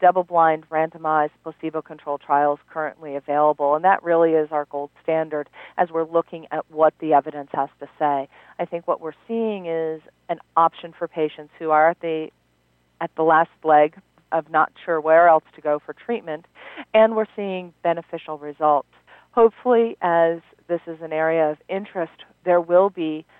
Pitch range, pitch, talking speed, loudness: 150-170 Hz, 160 Hz, 175 wpm, -21 LUFS